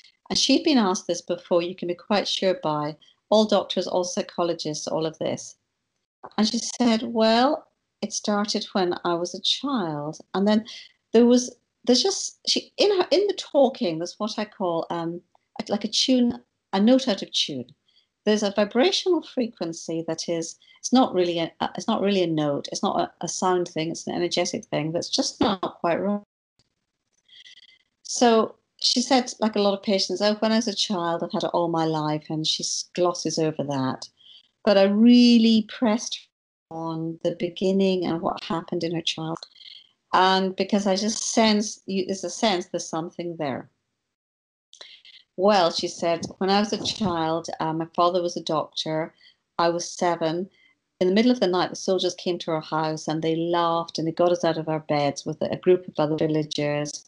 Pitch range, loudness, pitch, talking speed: 165-215 Hz, -24 LUFS, 185 Hz, 190 wpm